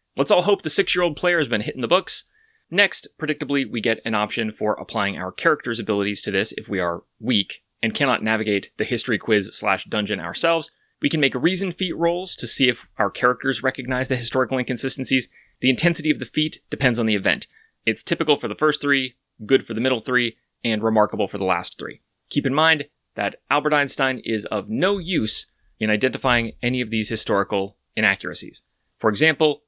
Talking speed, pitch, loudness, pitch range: 200 wpm, 130 Hz, -22 LUFS, 115-155 Hz